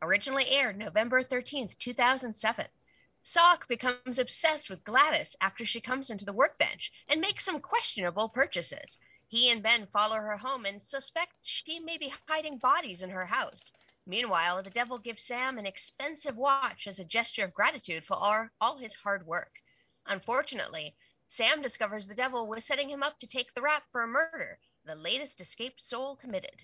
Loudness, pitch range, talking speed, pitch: -31 LUFS, 215-280 Hz, 175 wpm, 250 Hz